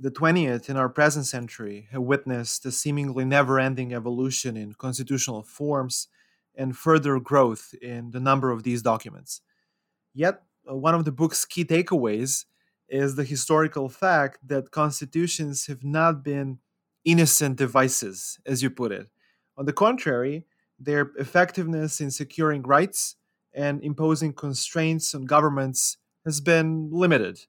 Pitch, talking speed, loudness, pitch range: 140 Hz, 140 wpm, -24 LUFS, 130-155 Hz